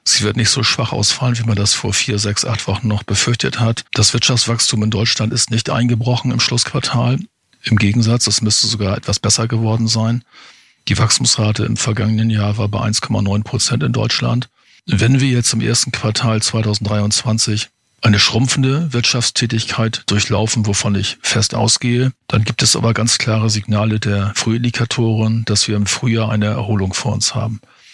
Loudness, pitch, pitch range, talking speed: -15 LUFS, 115 Hz, 105-120 Hz, 170 wpm